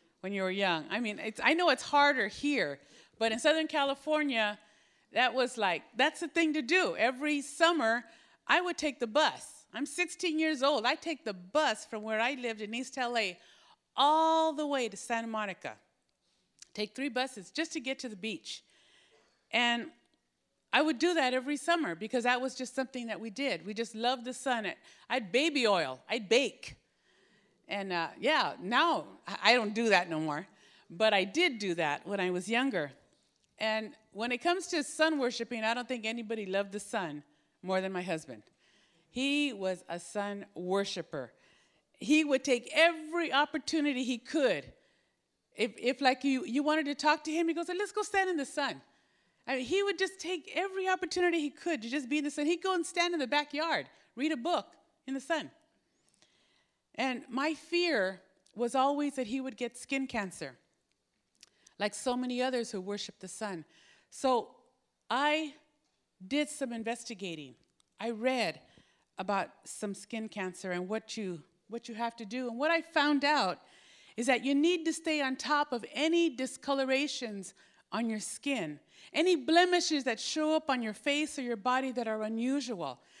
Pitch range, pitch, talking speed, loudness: 220-305 Hz, 255 Hz, 180 wpm, -32 LUFS